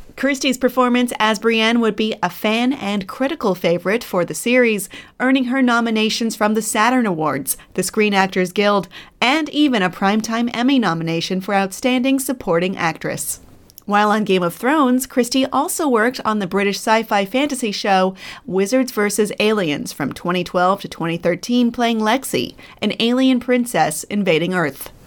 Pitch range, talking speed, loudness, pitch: 190-250 Hz, 155 wpm, -18 LUFS, 215 Hz